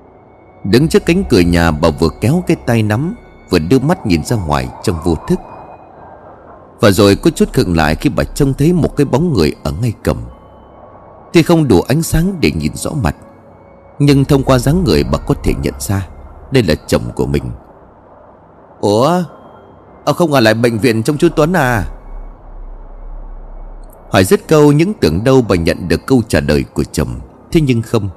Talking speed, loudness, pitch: 190 wpm, -13 LUFS, 115 Hz